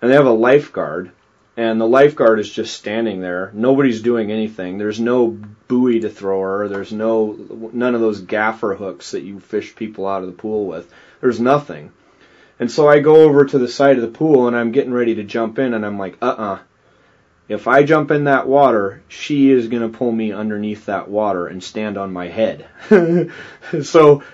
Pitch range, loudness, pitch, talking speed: 105-135 Hz, -16 LUFS, 115 Hz, 200 wpm